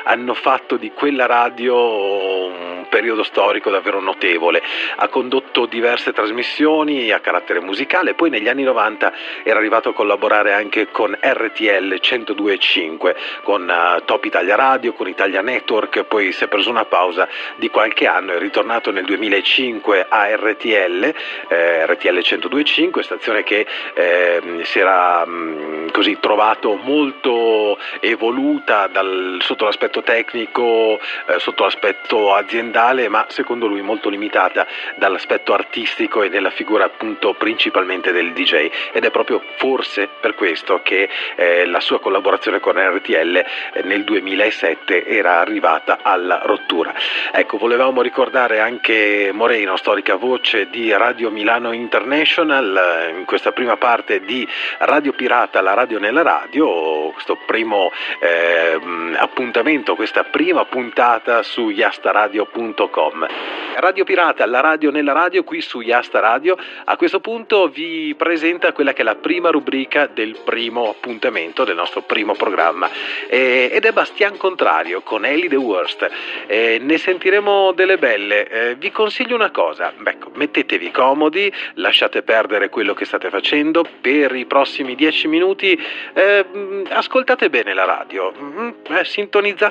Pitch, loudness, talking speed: 155 Hz, -16 LUFS, 140 wpm